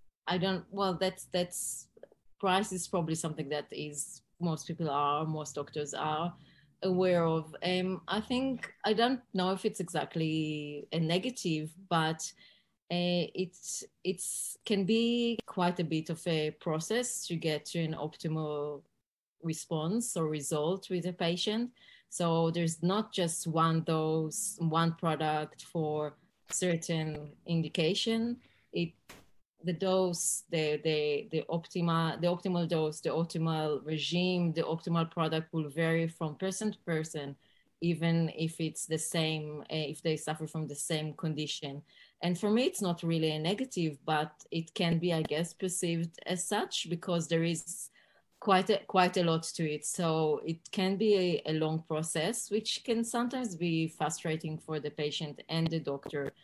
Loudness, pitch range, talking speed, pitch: -33 LUFS, 155-185 Hz, 155 wpm, 165 Hz